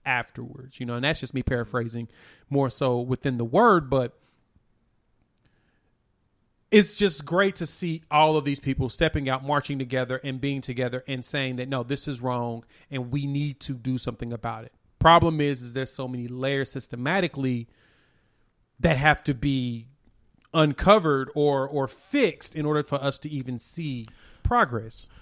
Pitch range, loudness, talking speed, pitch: 120-145 Hz, -25 LUFS, 165 wpm, 135 Hz